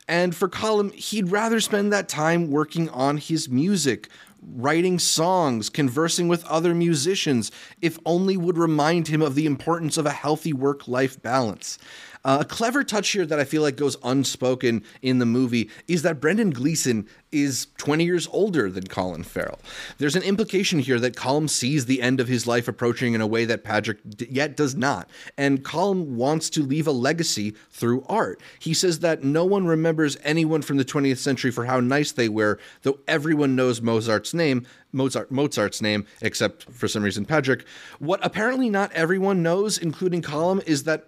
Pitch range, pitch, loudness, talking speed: 130-170 Hz, 150 Hz, -23 LUFS, 185 wpm